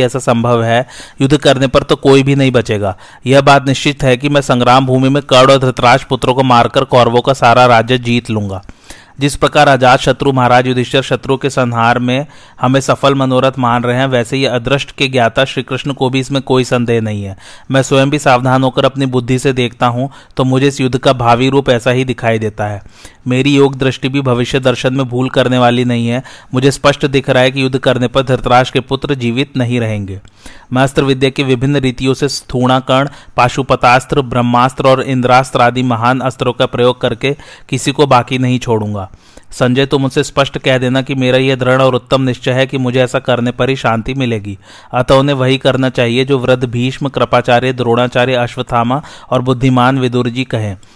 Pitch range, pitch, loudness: 125-135 Hz, 130 Hz, -12 LUFS